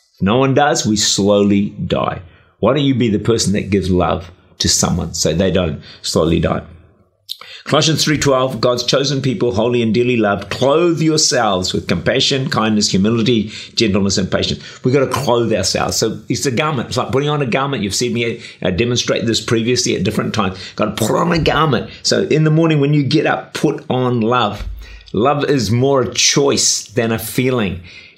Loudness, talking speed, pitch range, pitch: -15 LUFS, 190 wpm, 100-135 Hz, 115 Hz